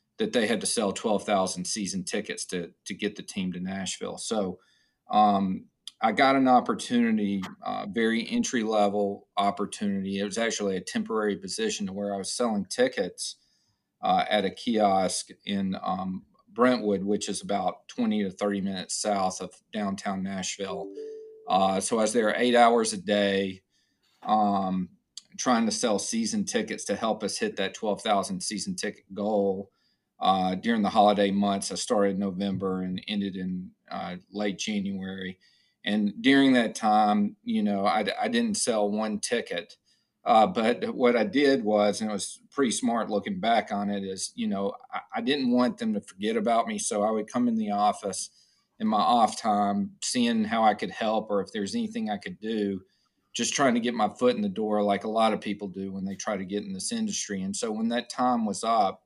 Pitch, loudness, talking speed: 105 Hz, -27 LUFS, 190 wpm